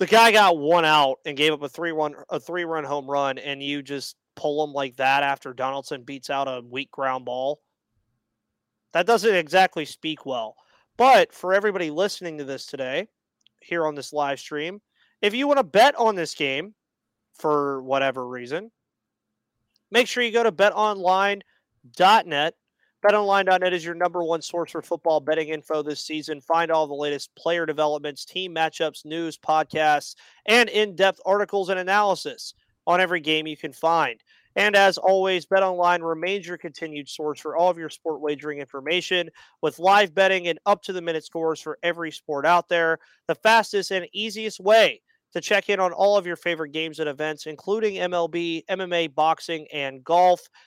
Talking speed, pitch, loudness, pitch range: 175 wpm, 165 Hz, -23 LUFS, 150-190 Hz